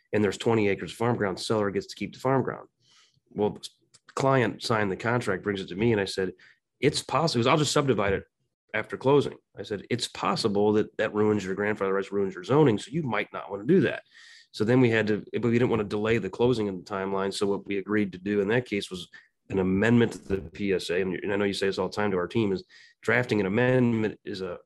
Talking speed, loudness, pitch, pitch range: 260 wpm, -27 LUFS, 105 Hz, 100-115 Hz